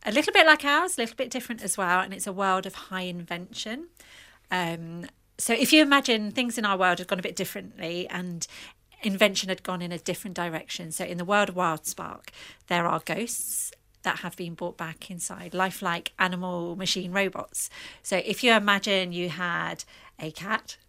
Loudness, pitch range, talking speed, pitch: -26 LUFS, 175-220 Hz, 195 wpm, 190 Hz